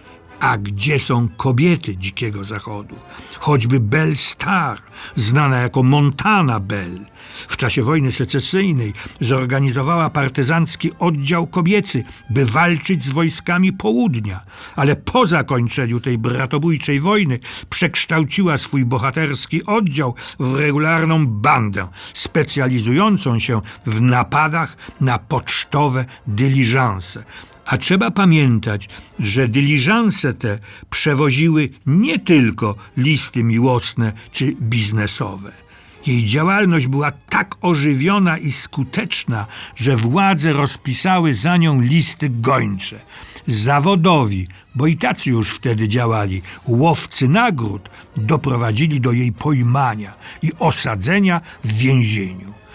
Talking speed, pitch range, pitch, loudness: 100 wpm, 115-160 Hz, 135 Hz, -17 LUFS